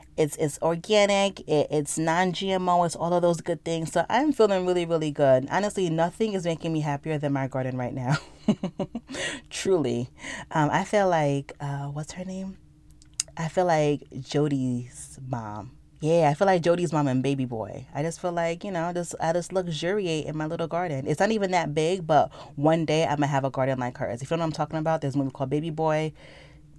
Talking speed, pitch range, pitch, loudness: 215 wpm, 145-175 Hz, 160 Hz, -26 LUFS